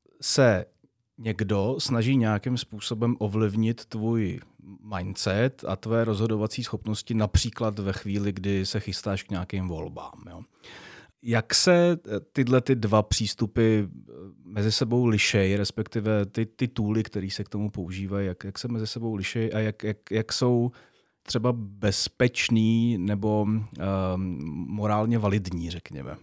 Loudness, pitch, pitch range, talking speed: -26 LUFS, 110 Hz, 100-115 Hz, 135 wpm